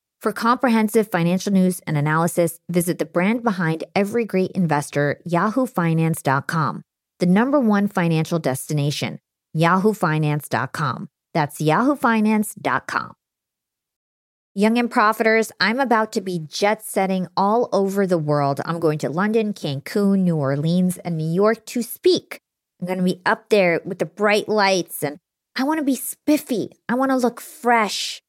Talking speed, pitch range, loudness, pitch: 140 wpm, 165-220 Hz, -20 LUFS, 185 Hz